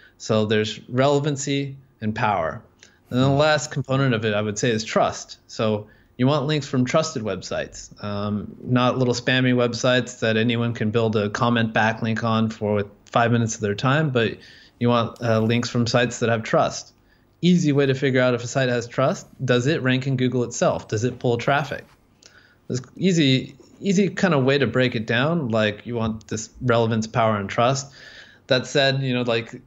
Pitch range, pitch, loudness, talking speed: 110-135 Hz, 120 Hz, -22 LUFS, 190 wpm